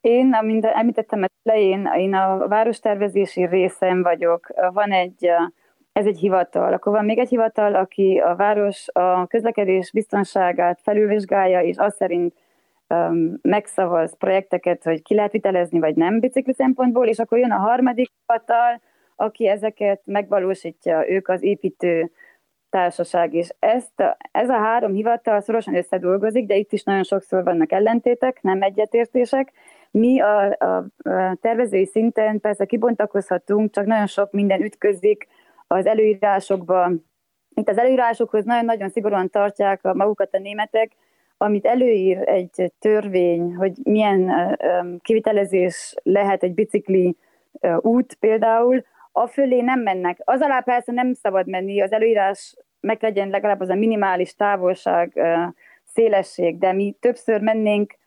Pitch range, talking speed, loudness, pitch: 185-225 Hz, 135 wpm, -20 LUFS, 205 Hz